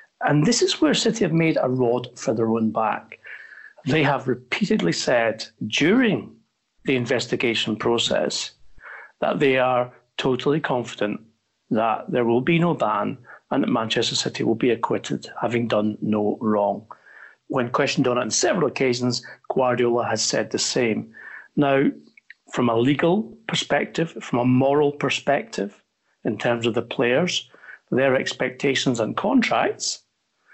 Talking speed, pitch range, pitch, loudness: 145 wpm, 120-145 Hz, 125 Hz, -22 LUFS